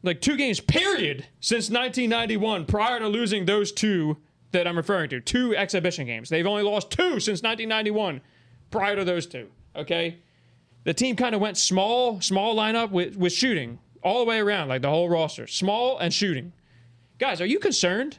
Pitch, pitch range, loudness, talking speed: 195 Hz, 165-225 Hz, -24 LUFS, 180 wpm